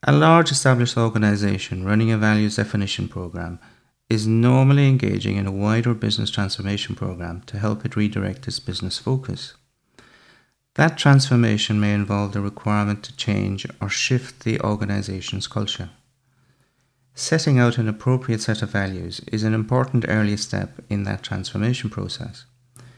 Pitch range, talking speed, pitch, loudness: 105-125 Hz, 140 wpm, 110 Hz, -21 LUFS